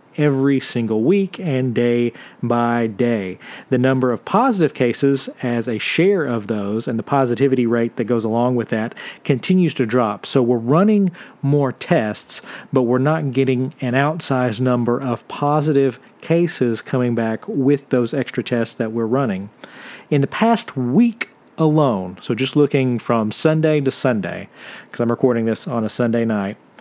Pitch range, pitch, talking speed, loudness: 120-145 Hz, 125 Hz, 165 wpm, -19 LUFS